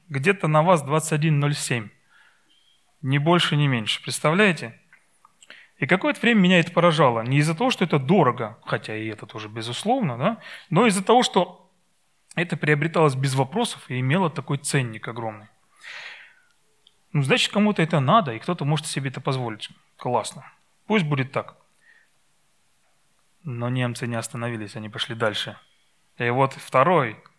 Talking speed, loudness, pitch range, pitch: 140 wpm, -22 LUFS, 125-185 Hz, 150 Hz